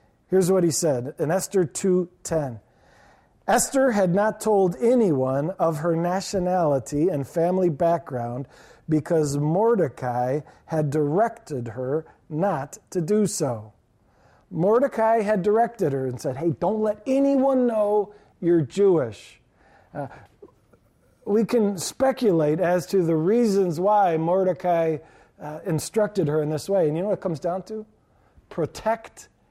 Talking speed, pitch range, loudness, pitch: 130 wpm, 155-210 Hz, -23 LUFS, 180 Hz